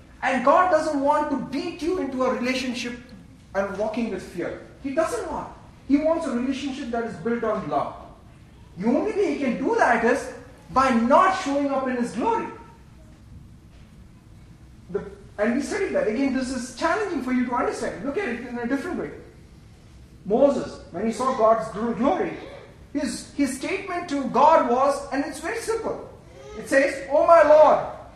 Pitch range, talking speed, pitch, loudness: 240-305 Hz, 175 wpm, 270 Hz, -23 LUFS